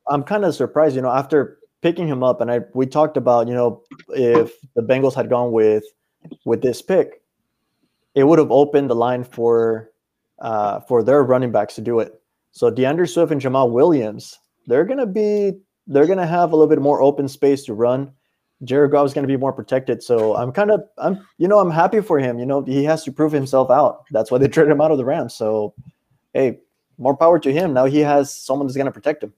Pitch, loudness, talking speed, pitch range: 140 Hz, -18 LUFS, 225 wpm, 125-155 Hz